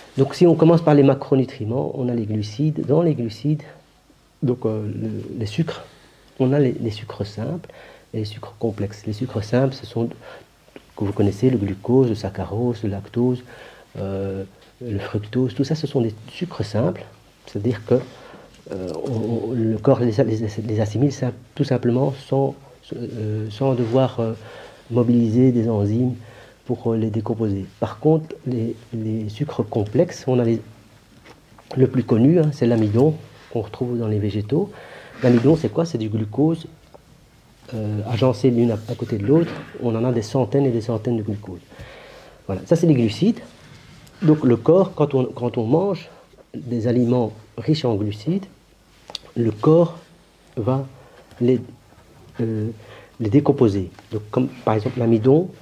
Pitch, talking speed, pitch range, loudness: 120 Hz, 160 wpm, 110-135 Hz, -21 LUFS